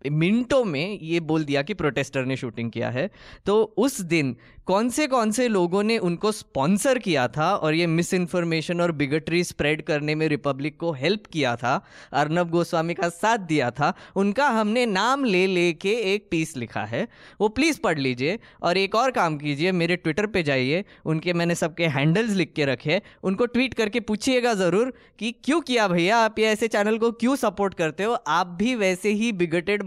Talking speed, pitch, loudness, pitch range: 195 wpm, 180 Hz, -23 LUFS, 155-220 Hz